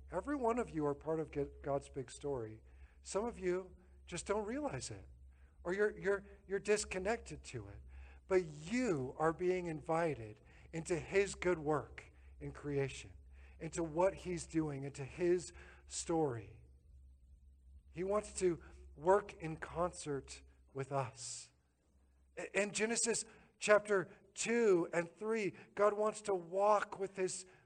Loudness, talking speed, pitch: -38 LUFS, 135 wpm, 160 Hz